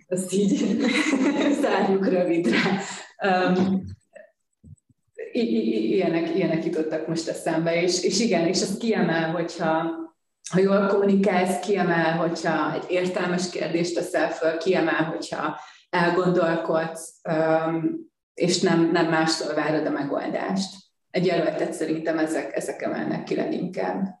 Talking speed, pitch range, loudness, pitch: 120 wpm, 165-195 Hz, -24 LUFS, 175 Hz